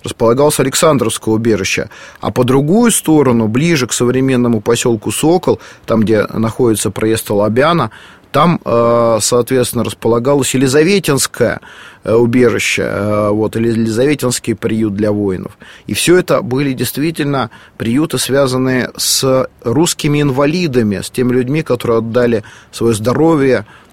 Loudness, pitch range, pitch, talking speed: -13 LUFS, 115-135 Hz, 125 Hz, 110 wpm